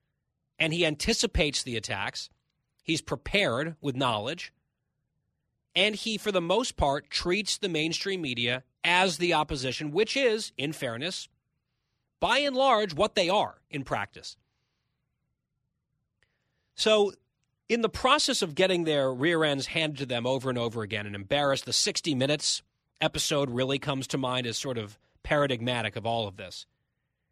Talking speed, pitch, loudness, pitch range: 150 wpm, 145 Hz, -27 LUFS, 125-180 Hz